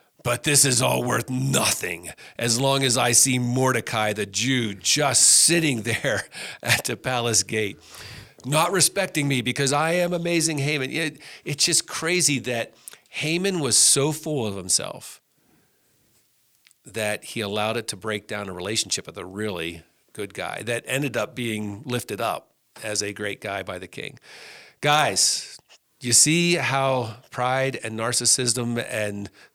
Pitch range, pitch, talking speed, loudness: 110-145 Hz, 125 Hz, 150 wpm, -22 LUFS